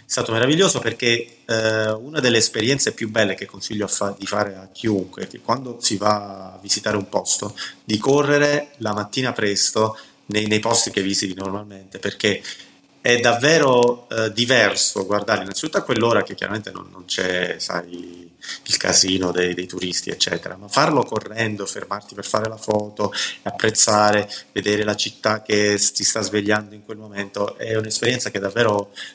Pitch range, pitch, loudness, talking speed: 100-115 Hz, 105 Hz, -20 LUFS, 170 wpm